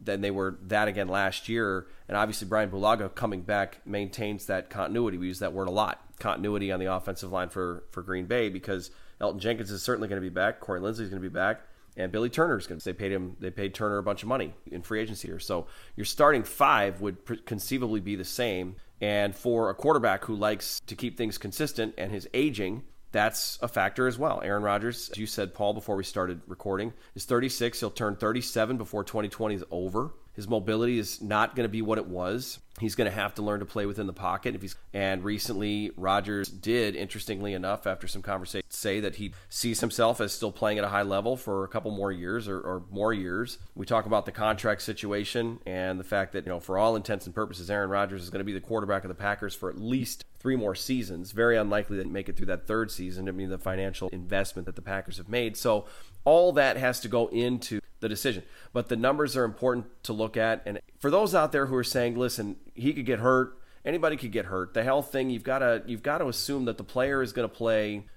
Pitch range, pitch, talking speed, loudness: 95-115 Hz, 105 Hz, 240 wpm, -29 LUFS